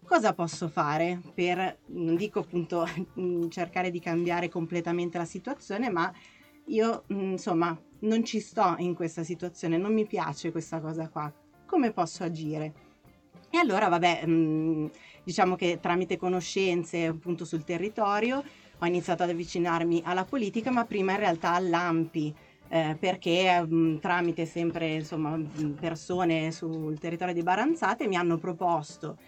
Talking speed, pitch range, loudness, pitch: 145 wpm, 165-185 Hz, -29 LUFS, 175 Hz